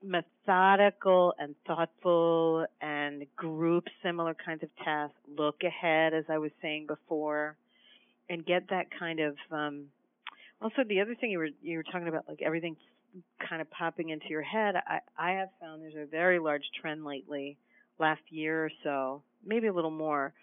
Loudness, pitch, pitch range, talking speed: -32 LUFS, 160 Hz, 150-175 Hz, 170 wpm